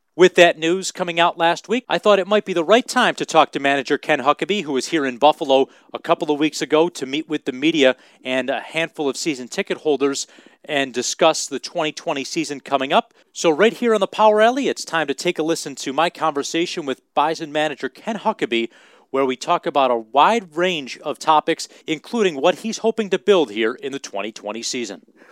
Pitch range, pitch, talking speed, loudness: 140-185 Hz, 160 Hz, 215 wpm, -19 LUFS